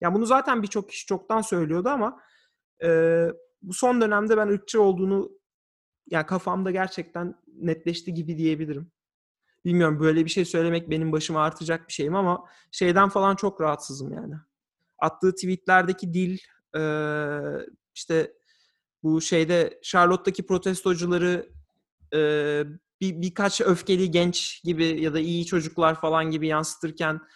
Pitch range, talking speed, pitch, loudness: 160-190 Hz, 130 wpm, 175 Hz, -25 LUFS